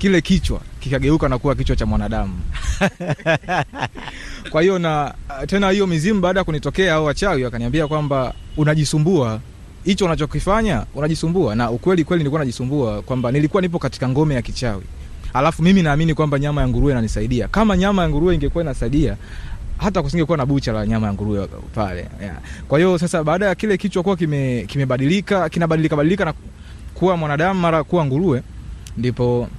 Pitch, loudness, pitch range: 145 Hz, -19 LUFS, 120-175 Hz